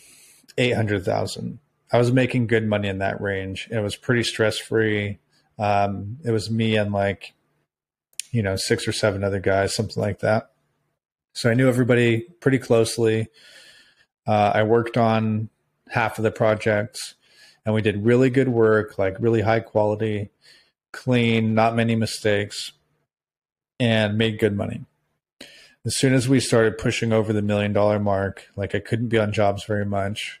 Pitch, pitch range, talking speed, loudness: 110 Hz, 105-115 Hz, 160 wpm, -22 LUFS